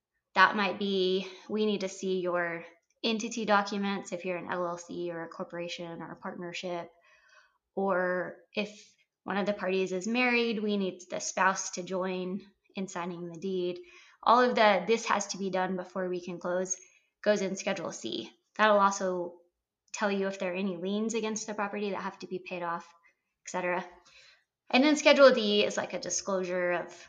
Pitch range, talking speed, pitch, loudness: 180-205 Hz, 185 wpm, 190 Hz, -30 LUFS